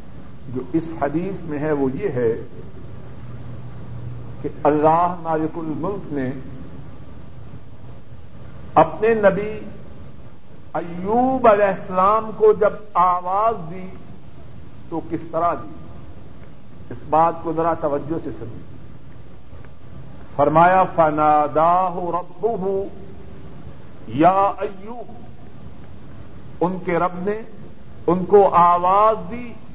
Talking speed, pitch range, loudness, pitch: 95 wpm, 150-195 Hz, -19 LUFS, 170 Hz